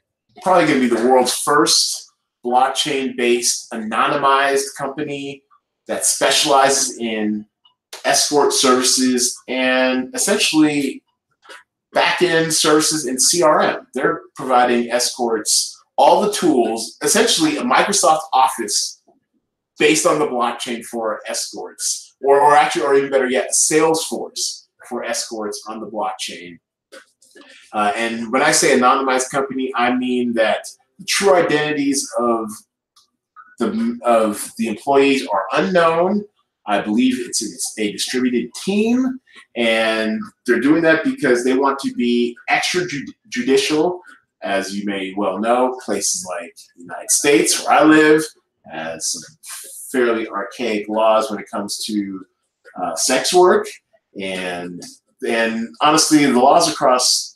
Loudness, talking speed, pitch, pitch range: -17 LUFS, 125 wpm, 130 Hz, 115-155 Hz